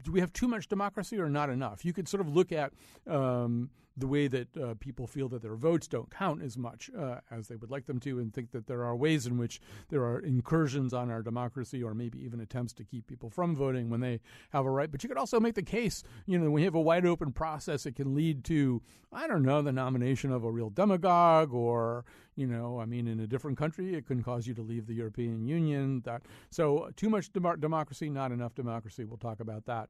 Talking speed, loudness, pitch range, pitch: 245 wpm, -33 LUFS, 120-160 Hz, 135 Hz